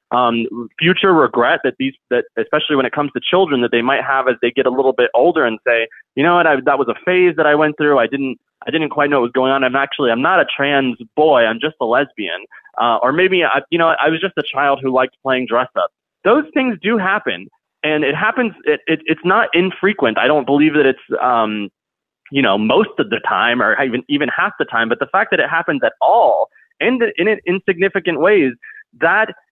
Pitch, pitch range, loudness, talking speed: 150 Hz, 130-185 Hz, -15 LUFS, 240 wpm